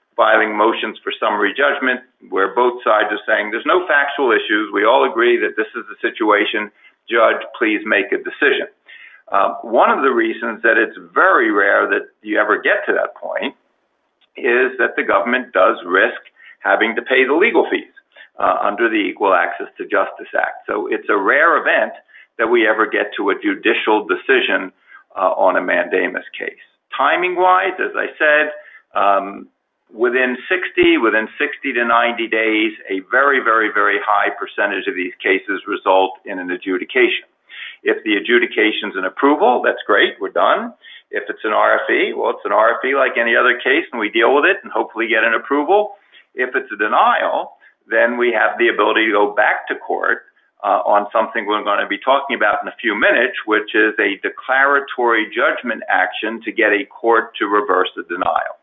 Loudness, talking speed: -16 LUFS, 185 wpm